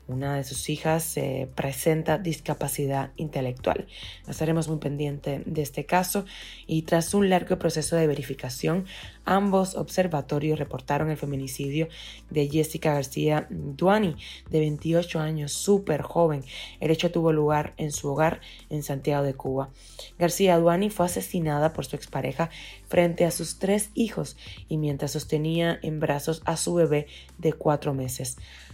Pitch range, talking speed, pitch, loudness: 145-170 Hz, 145 wpm, 155 Hz, -26 LUFS